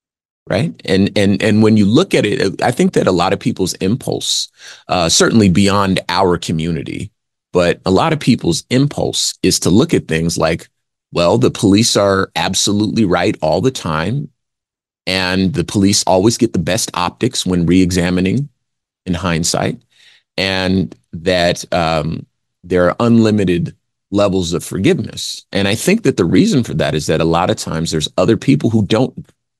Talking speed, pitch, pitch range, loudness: 170 wpm, 95 Hz, 90-110 Hz, -15 LUFS